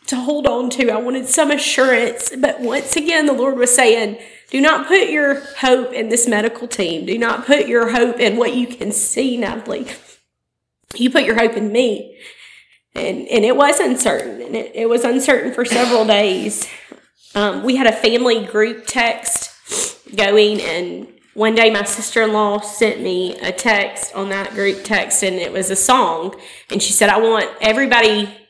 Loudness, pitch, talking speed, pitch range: -16 LUFS, 230 Hz, 180 wpm, 215-255 Hz